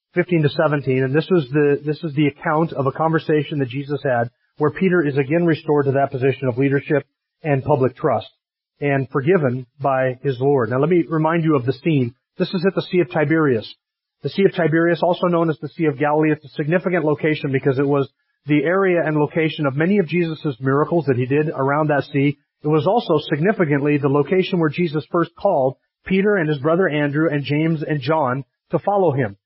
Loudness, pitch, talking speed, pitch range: -19 LUFS, 150 Hz, 215 wpm, 140-170 Hz